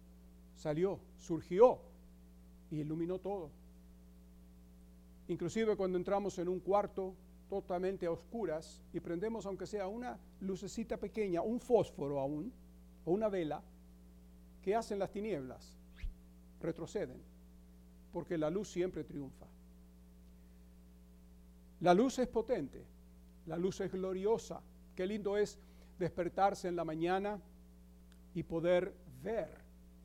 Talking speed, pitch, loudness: 110 wpm, 155 Hz, -38 LUFS